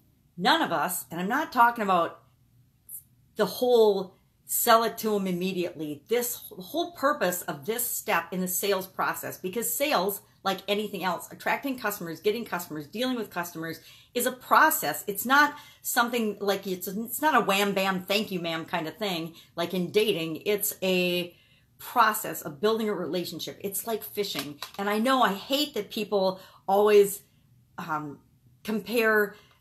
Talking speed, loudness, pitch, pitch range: 160 wpm, -27 LUFS, 195 Hz, 170-220 Hz